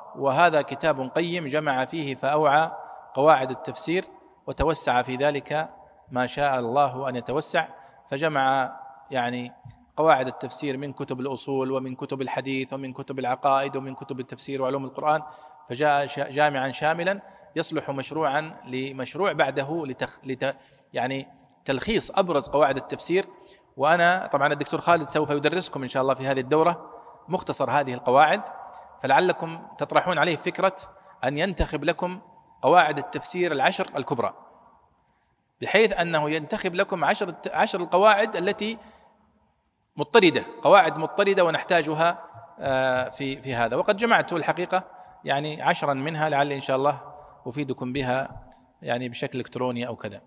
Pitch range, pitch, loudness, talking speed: 135-170 Hz, 145 Hz, -24 LUFS, 125 wpm